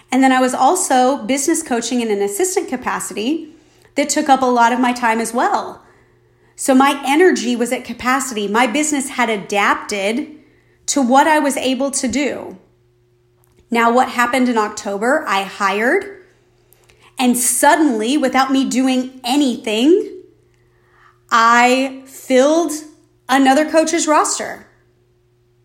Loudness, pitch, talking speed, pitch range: -15 LUFS, 255 Hz, 130 wpm, 230-290 Hz